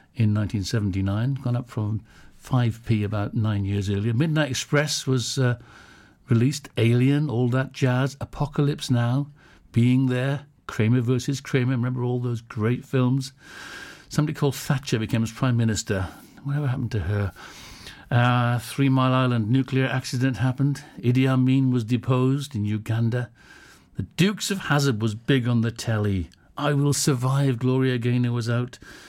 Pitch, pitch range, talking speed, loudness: 125 Hz, 115-135 Hz, 145 wpm, -24 LUFS